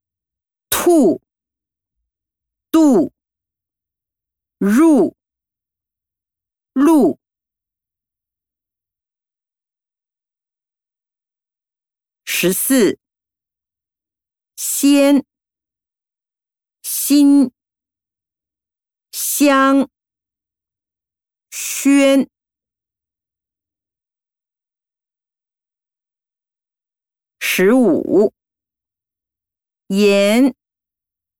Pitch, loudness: 105 Hz, -14 LUFS